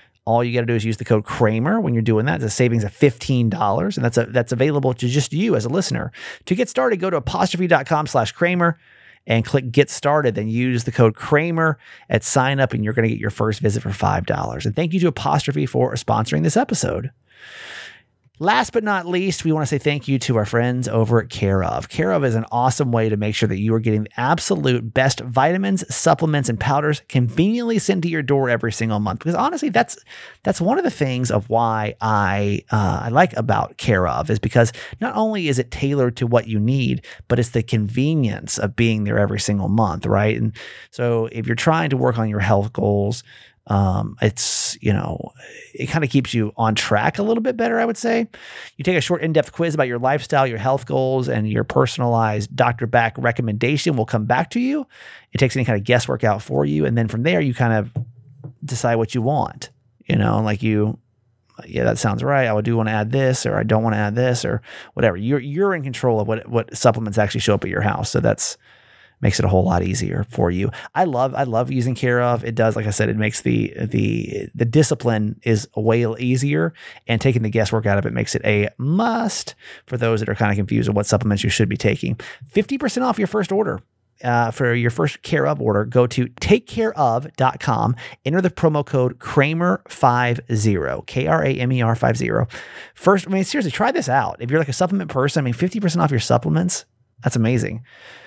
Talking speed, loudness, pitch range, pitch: 220 wpm, -20 LUFS, 110-145 Hz, 120 Hz